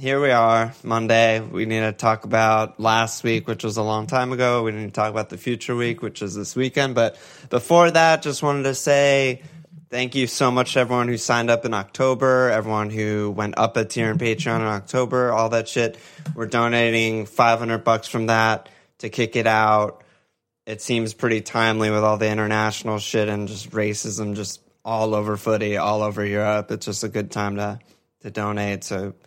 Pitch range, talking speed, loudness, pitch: 105-120 Hz, 200 wpm, -21 LUFS, 110 Hz